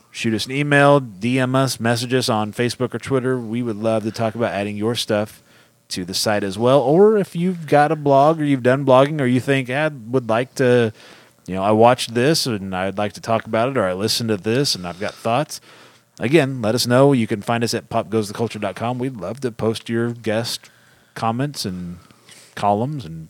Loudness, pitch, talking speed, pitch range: -19 LUFS, 120 Hz, 215 wpm, 110-135 Hz